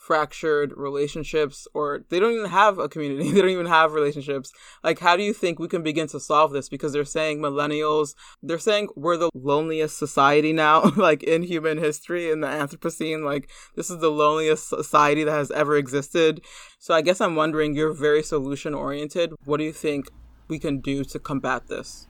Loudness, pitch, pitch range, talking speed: -23 LUFS, 155 Hz, 145-160 Hz, 195 wpm